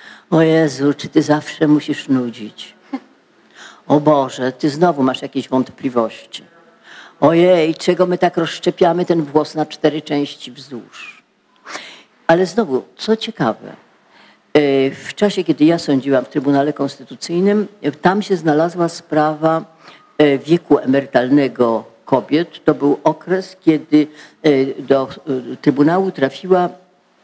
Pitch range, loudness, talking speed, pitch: 140-175 Hz, -16 LUFS, 110 wpm, 150 Hz